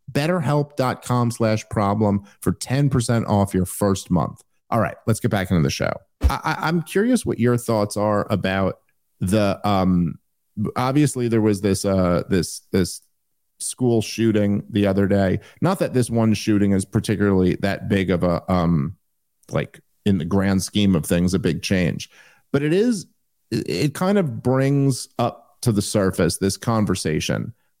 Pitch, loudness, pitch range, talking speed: 105 Hz, -21 LUFS, 95-125 Hz, 160 wpm